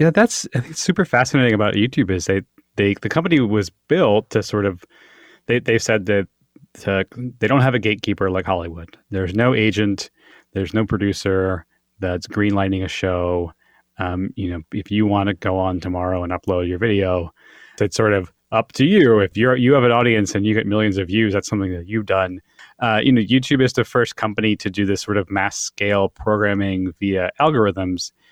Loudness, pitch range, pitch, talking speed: -19 LUFS, 95-110 Hz, 100 Hz, 200 wpm